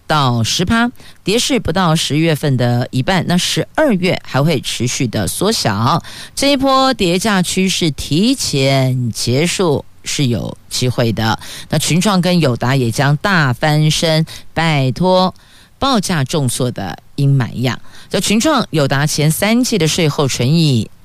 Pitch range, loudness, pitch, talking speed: 130-190 Hz, -15 LUFS, 155 Hz, 210 characters per minute